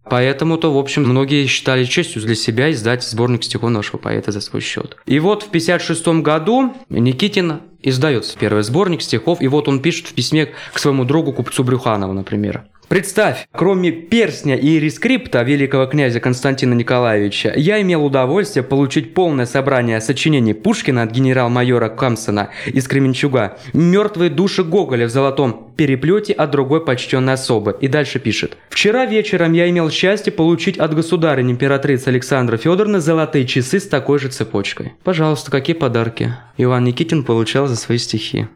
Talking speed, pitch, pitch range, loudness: 155 wpm, 140 Hz, 125-165 Hz, -16 LUFS